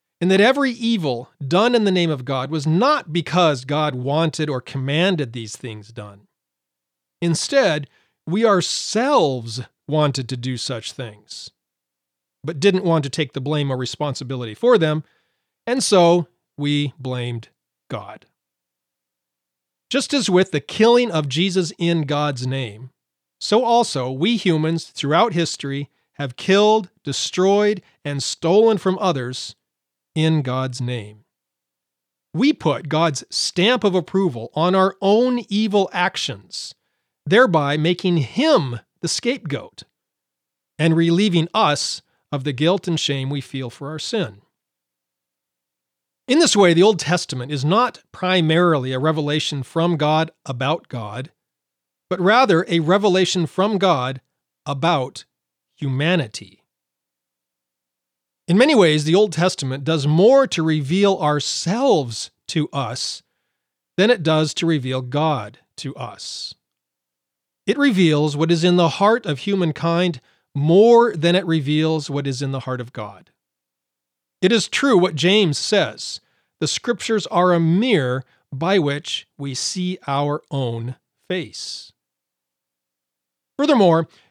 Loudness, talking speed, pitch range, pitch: -19 LUFS, 130 wpm, 115-180 Hz, 150 Hz